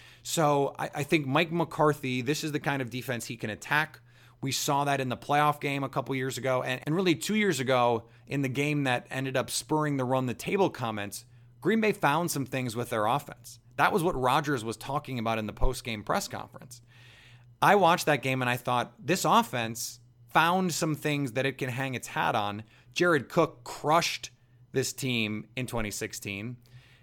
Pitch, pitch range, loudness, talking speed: 130 Hz, 120-150 Hz, -28 LUFS, 195 wpm